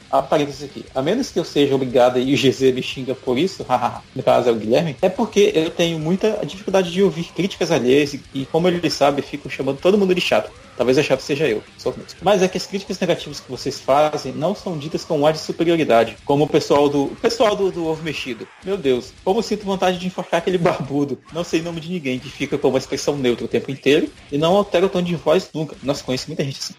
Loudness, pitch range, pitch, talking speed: -19 LUFS, 135-180 Hz, 155 Hz, 250 wpm